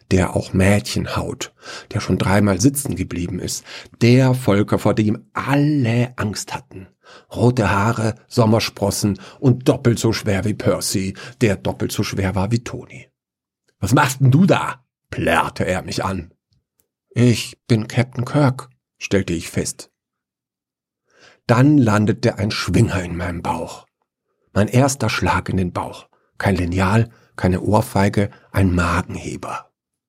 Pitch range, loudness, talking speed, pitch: 95-120 Hz, -19 LUFS, 135 wpm, 105 Hz